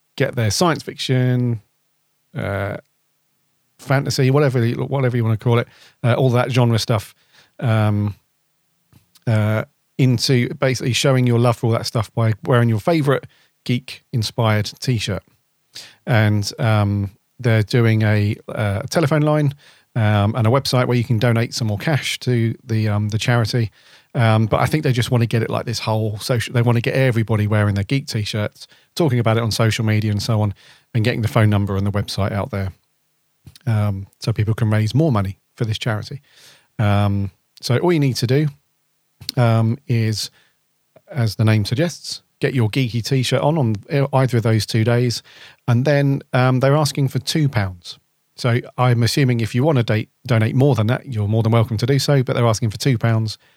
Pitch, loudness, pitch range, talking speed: 120 Hz, -19 LUFS, 110-135 Hz, 190 wpm